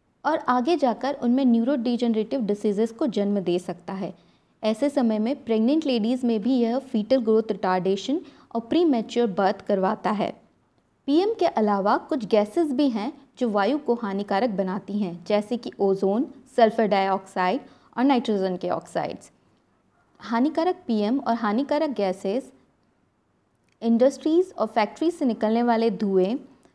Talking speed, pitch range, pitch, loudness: 135 wpm, 205-275 Hz, 230 Hz, -24 LUFS